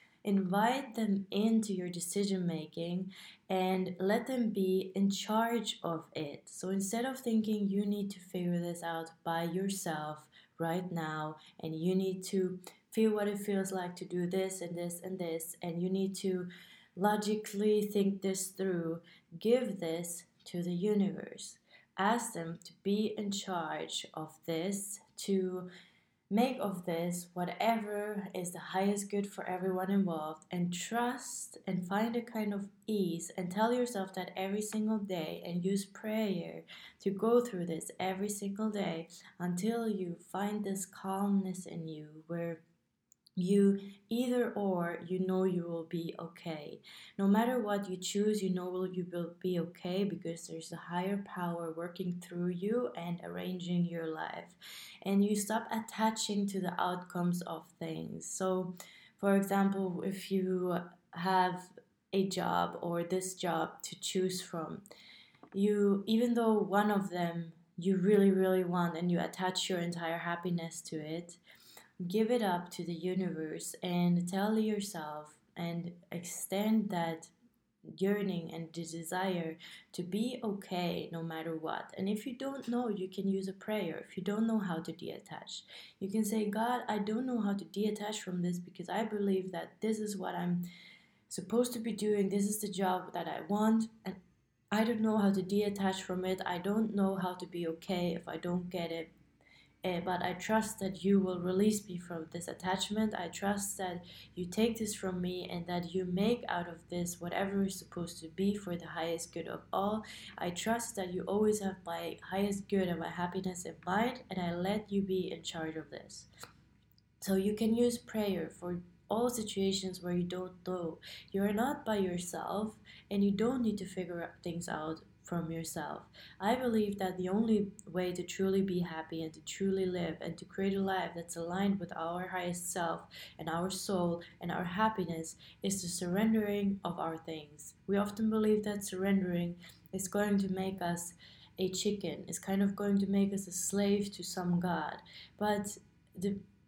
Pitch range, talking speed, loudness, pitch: 175-205 Hz, 175 wpm, -35 LUFS, 185 Hz